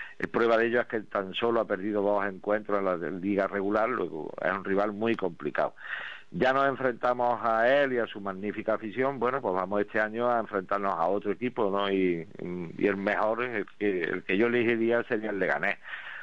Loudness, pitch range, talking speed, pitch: -28 LUFS, 100-120 Hz, 205 wpm, 105 Hz